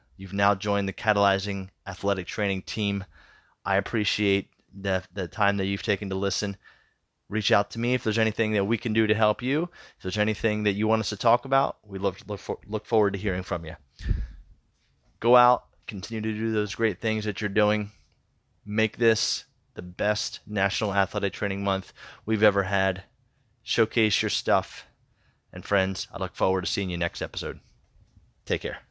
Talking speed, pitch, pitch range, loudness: 185 wpm, 105 Hz, 95-110 Hz, -26 LUFS